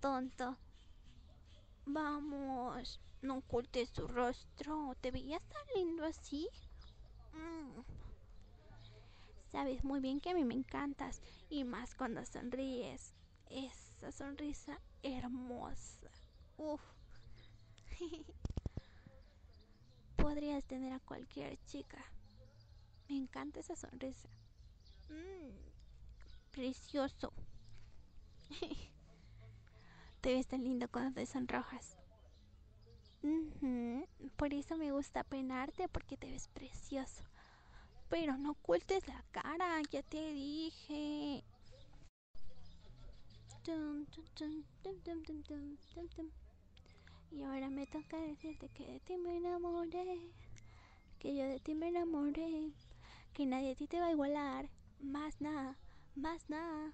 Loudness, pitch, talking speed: -44 LUFS, 270 Hz, 95 wpm